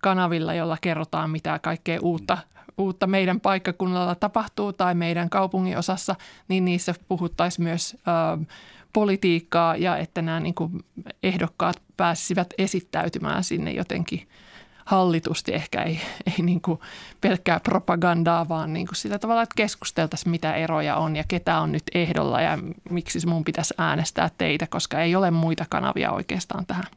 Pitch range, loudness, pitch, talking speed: 165-185 Hz, -24 LUFS, 175 Hz, 145 wpm